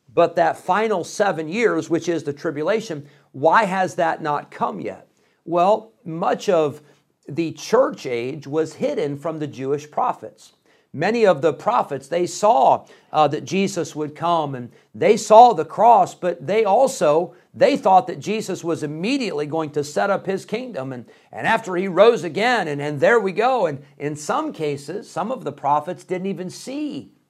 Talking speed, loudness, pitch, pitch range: 175 wpm, -20 LUFS, 165 Hz, 150-205 Hz